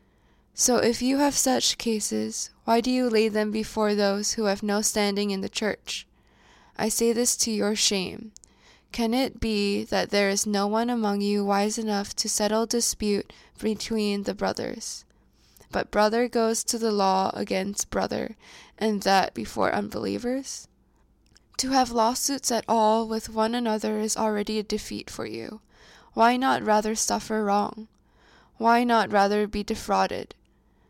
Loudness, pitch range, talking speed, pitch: -25 LUFS, 205-230 Hz, 155 wpm, 215 Hz